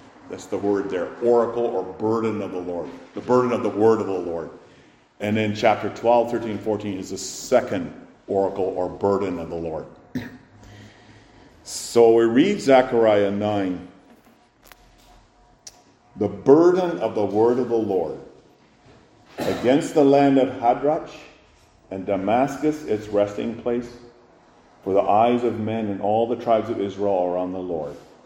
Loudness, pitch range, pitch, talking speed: -21 LUFS, 95-120 Hz, 105 Hz, 150 wpm